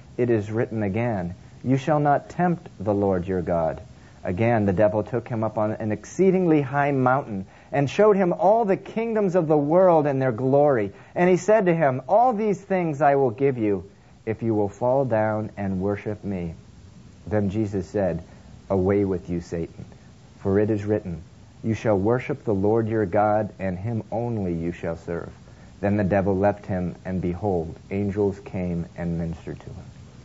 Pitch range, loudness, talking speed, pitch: 100-140 Hz, -23 LUFS, 185 wpm, 110 Hz